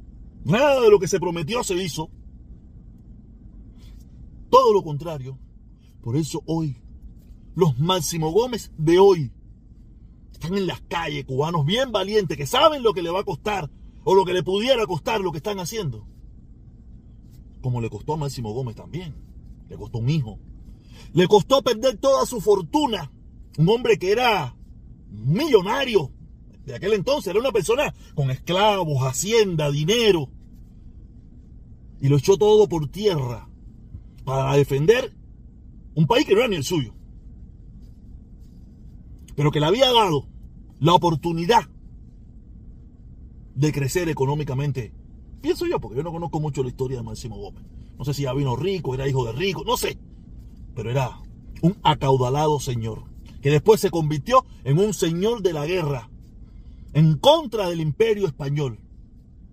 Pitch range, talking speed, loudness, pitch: 125-195 Hz, 145 wpm, -21 LUFS, 150 Hz